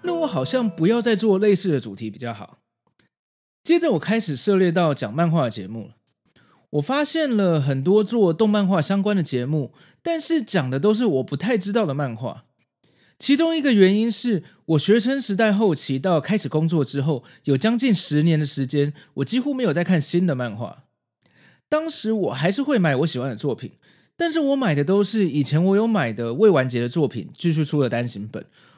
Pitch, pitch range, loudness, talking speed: 180 Hz, 145-225 Hz, -21 LUFS, 290 characters per minute